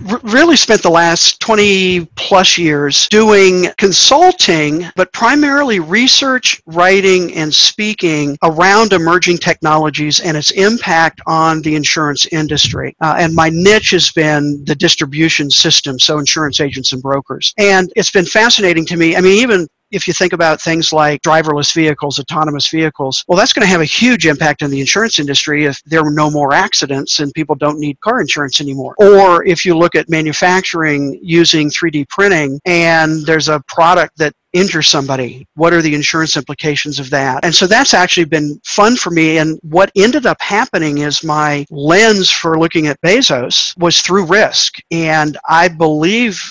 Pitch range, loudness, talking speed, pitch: 150-185 Hz, -10 LUFS, 170 wpm, 165 Hz